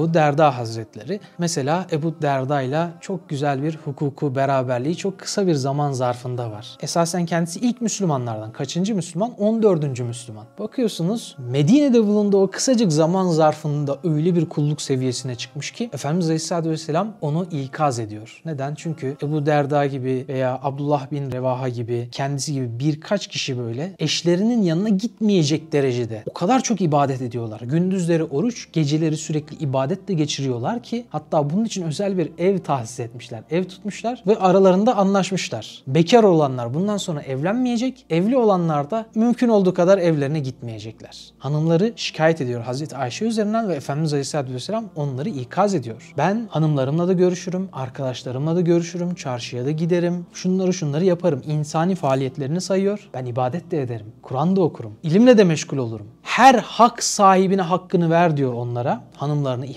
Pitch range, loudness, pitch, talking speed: 135-185 Hz, -21 LUFS, 160 Hz, 150 wpm